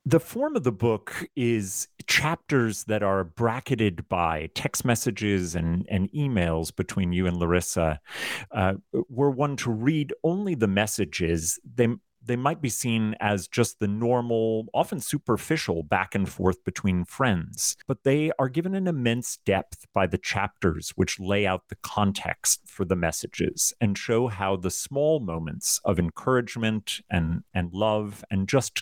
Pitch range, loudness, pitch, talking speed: 95-125 Hz, -26 LUFS, 110 Hz, 155 wpm